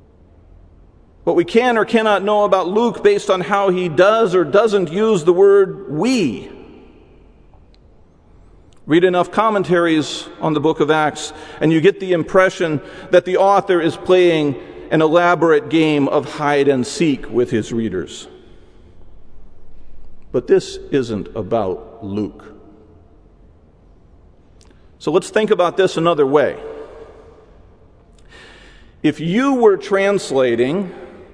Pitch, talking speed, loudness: 165 Hz, 120 wpm, -16 LUFS